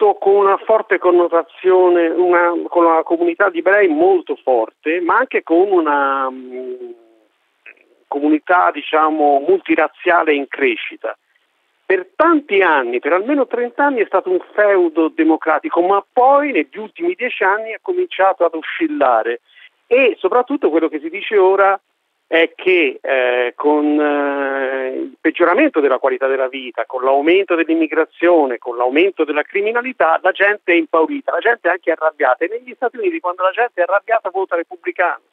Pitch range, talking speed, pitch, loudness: 155-240 Hz, 150 wpm, 180 Hz, -15 LUFS